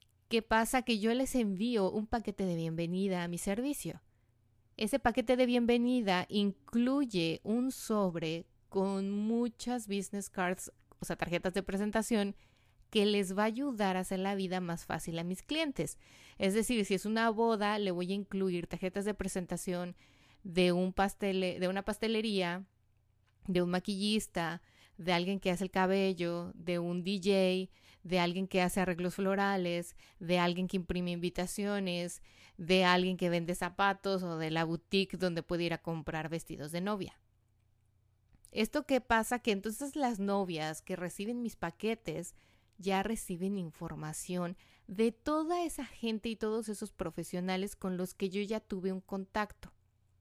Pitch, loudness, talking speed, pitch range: 190 Hz, -34 LUFS, 160 wpm, 175-215 Hz